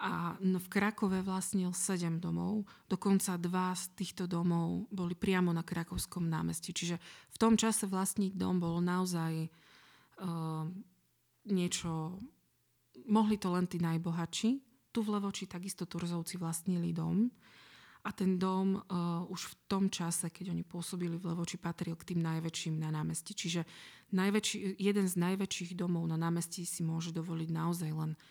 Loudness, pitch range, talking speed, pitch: -35 LUFS, 170-195 Hz, 150 wpm, 180 Hz